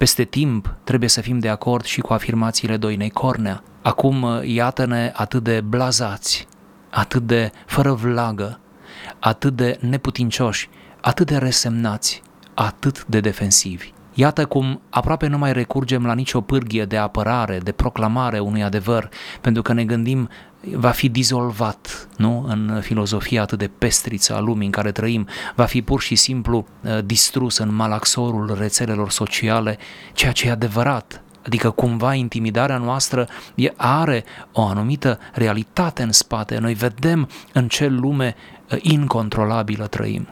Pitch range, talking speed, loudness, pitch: 110-130 Hz, 140 wpm, -19 LUFS, 120 Hz